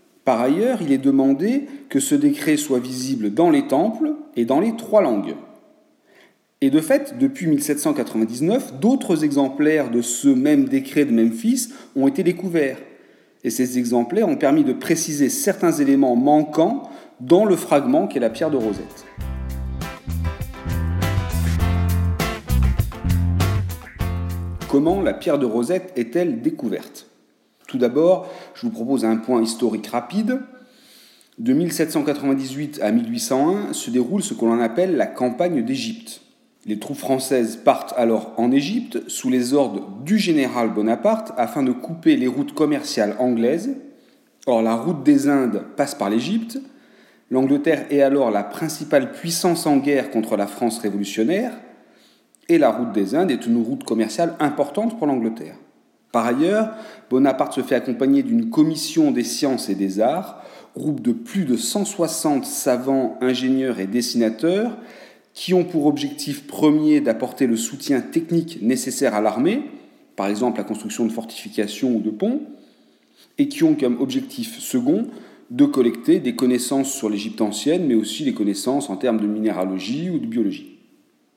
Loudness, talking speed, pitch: -20 LUFS, 145 wpm, 150 Hz